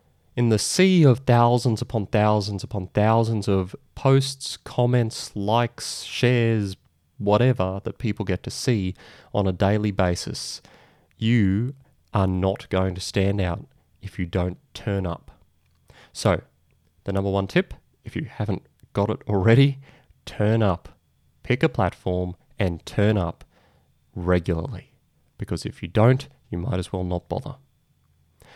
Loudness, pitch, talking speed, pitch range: -23 LUFS, 100 Hz, 140 wpm, 90-120 Hz